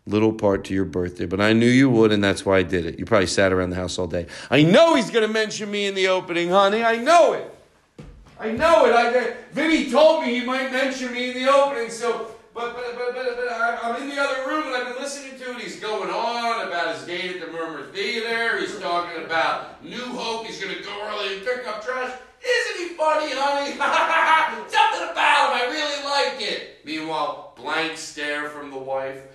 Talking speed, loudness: 225 wpm, -21 LUFS